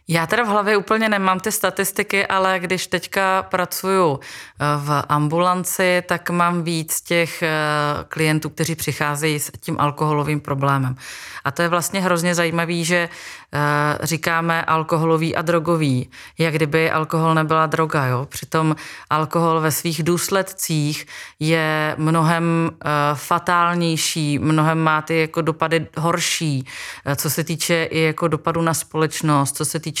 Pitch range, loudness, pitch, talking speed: 155-175 Hz, -19 LUFS, 160 Hz, 135 wpm